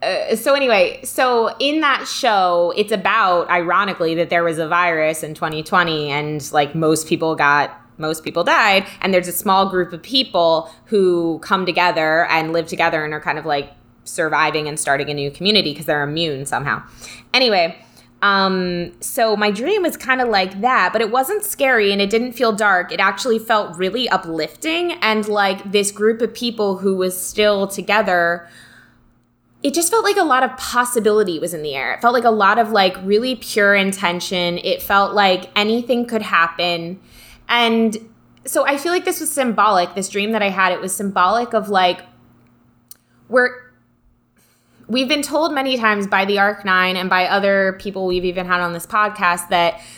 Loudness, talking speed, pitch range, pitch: -17 LUFS, 185 wpm, 170-225 Hz, 195 Hz